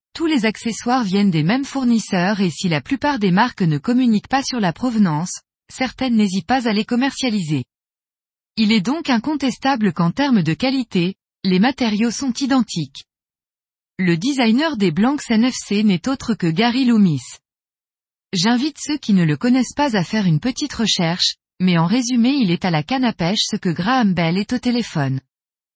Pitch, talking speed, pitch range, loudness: 220 Hz, 175 wpm, 180-255 Hz, -18 LUFS